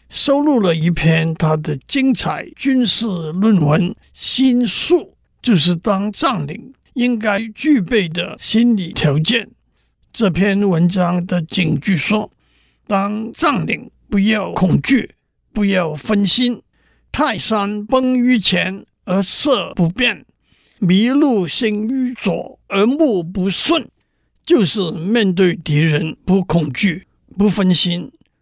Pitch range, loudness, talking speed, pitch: 175-235 Hz, -16 LUFS, 165 characters per minute, 200 Hz